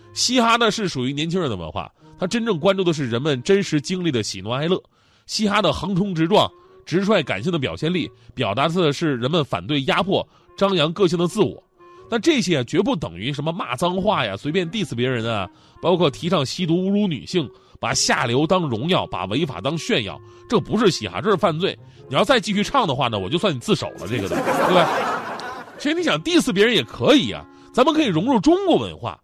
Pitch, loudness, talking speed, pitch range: 180 Hz, -20 LUFS, 330 characters per minute, 140-210 Hz